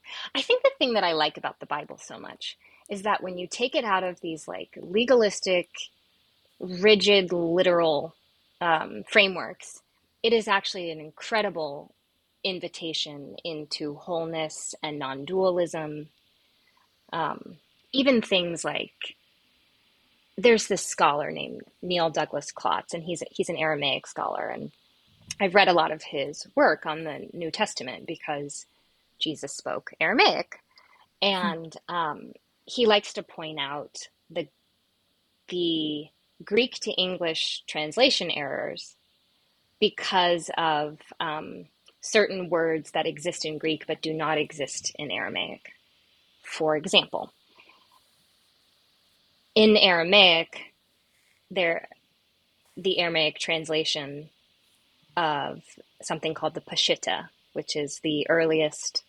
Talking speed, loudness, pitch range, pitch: 120 wpm, -25 LUFS, 155-195 Hz, 170 Hz